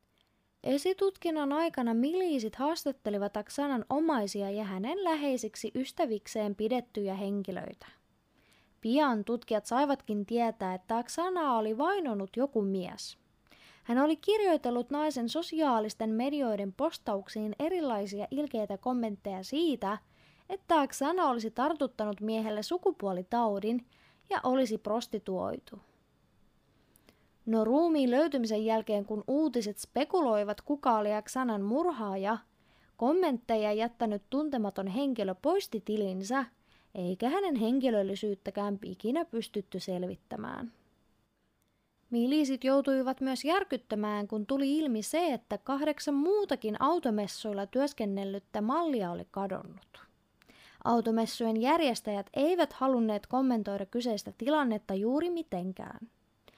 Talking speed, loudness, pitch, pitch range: 95 wpm, -32 LUFS, 235 Hz, 210-285 Hz